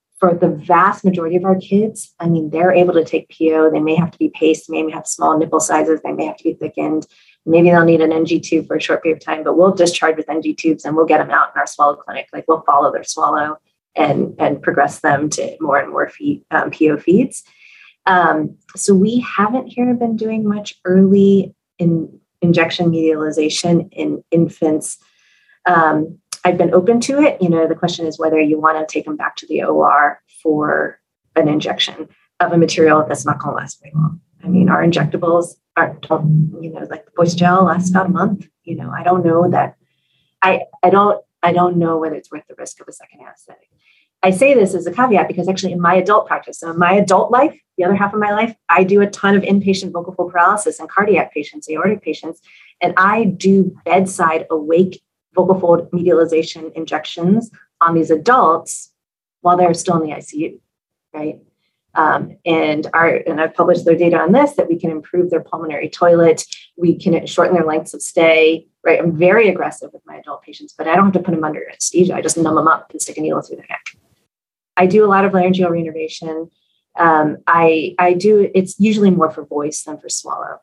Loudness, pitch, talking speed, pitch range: -15 LUFS, 170 Hz, 215 wpm, 160-185 Hz